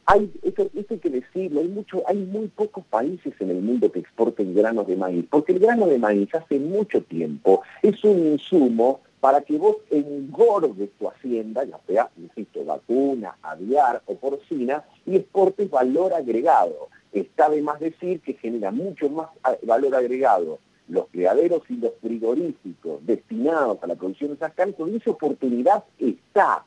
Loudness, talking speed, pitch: -22 LUFS, 165 wpm, 160 Hz